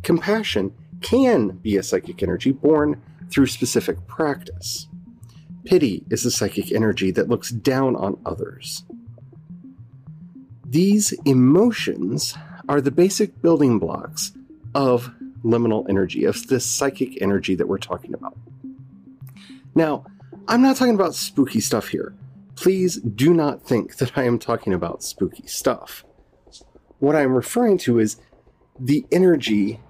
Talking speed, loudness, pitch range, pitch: 130 wpm, -21 LUFS, 115-170 Hz, 130 Hz